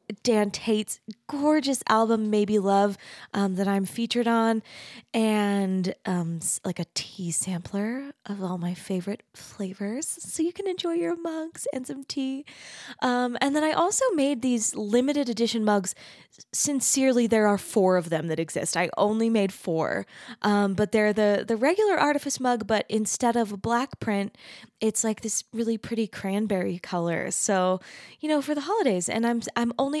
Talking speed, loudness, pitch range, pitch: 170 wpm, -26 LUFS, 200-265 Hz, 220 Hz